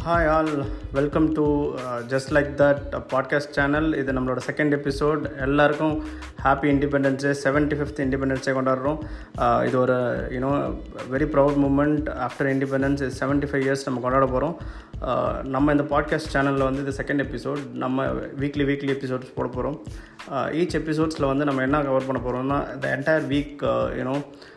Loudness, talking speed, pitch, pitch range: -24 LUFS, 150 wpm, 140 Hz, 135-145 Hz